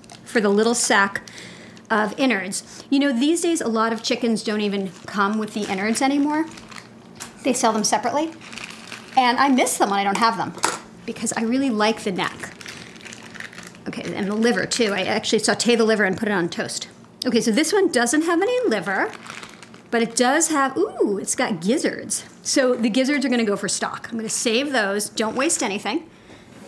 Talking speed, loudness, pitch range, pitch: 195 wpm, -21 LUFS, 215-270 Hz, 230 Hz